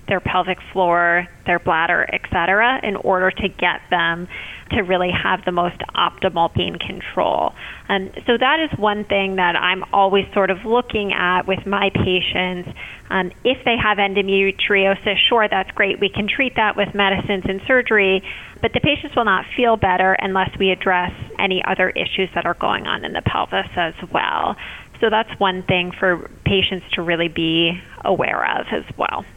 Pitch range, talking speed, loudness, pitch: 180-205 Hz, 180 wpm, -18 LUFS, 190 Hz